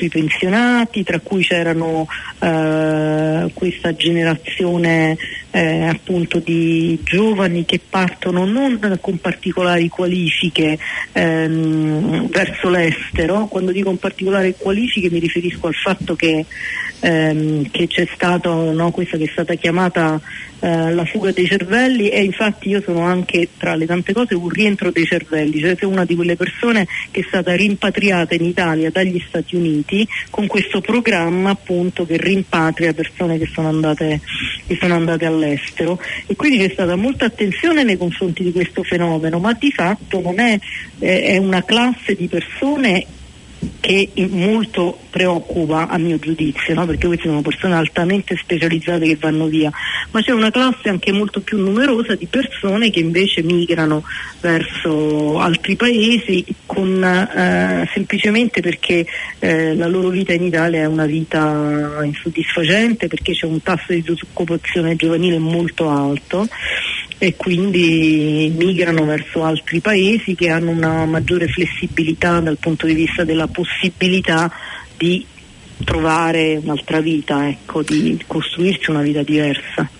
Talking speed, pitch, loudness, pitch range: 140 wpm, 175 Hz, -17 LUFS, 160-190 Hz